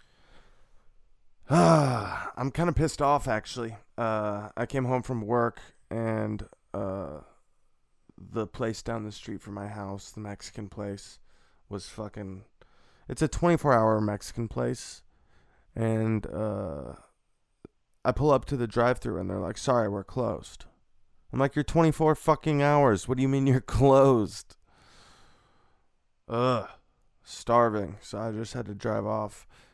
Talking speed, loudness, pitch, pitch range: 135 wpm, -28 LUFS, 110 Hz, 100-130 Hz